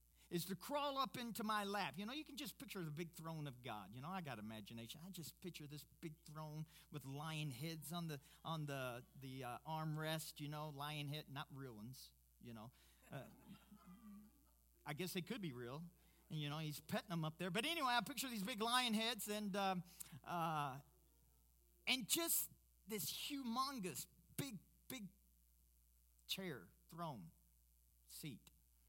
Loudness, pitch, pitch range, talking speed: -46 LUFS, 155 Hz, 125-195 Hz, 170 wpm